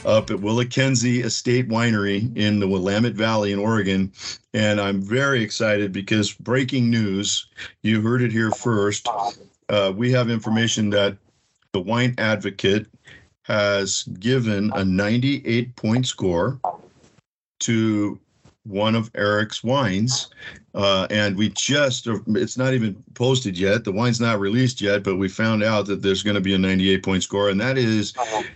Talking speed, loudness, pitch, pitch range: 155 wpm, -21 LUFS, 110 Hz, 100-120 Hz